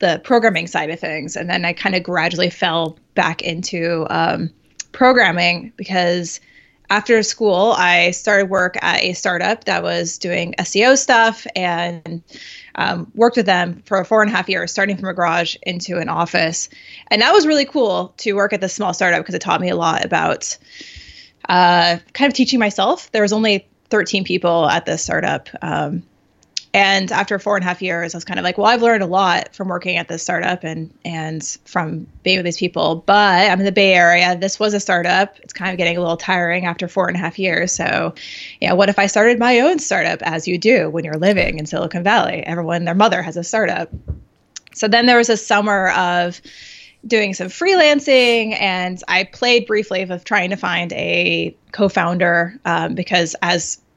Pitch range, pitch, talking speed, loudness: 175-210 Hz, 185 Hz, 200 wpm, -16 LUFS